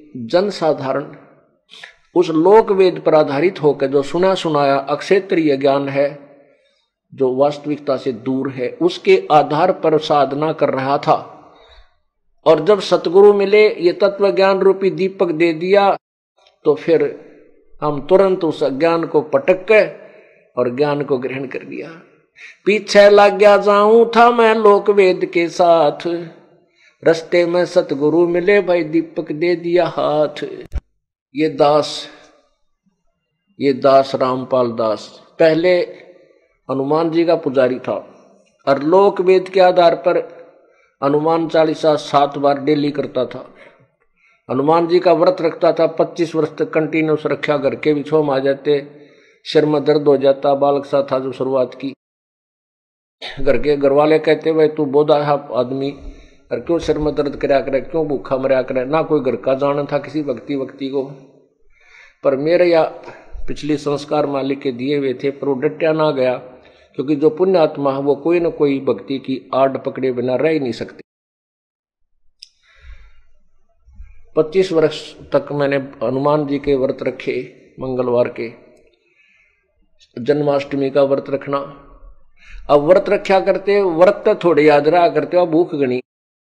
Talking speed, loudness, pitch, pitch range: 140 wpm, -16 LUFS, 150 Hz, 140-175 Hz